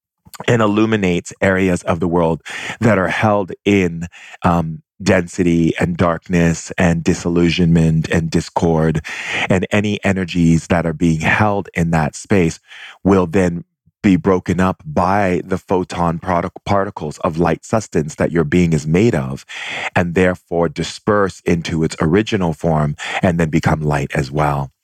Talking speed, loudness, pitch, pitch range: 145 wpm, -17 LUFS, 85 Hz, 80-95 Hz